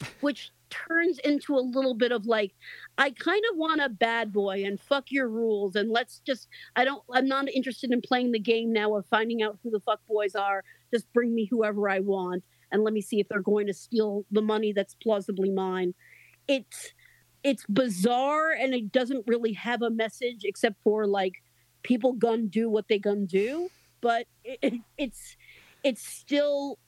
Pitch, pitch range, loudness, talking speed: 230 Hz, 210-260 Hz, -28 LUFS, 190 wpm